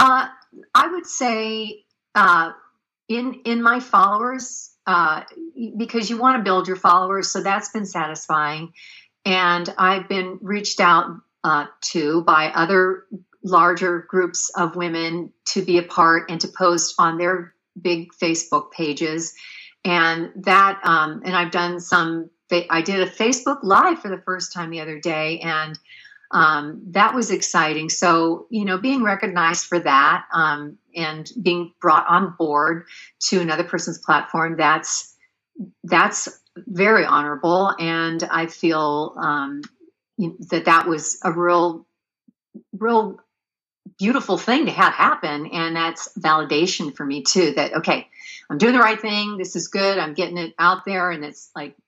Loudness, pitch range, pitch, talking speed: -19 LUFS, 165-210 Hz, 180 Hz, 150 wpm